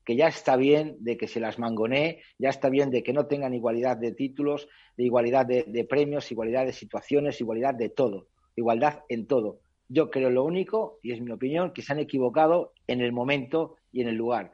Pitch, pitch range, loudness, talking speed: 130 Hz, 120-145 Hz, -27 LUFS, 215 wpm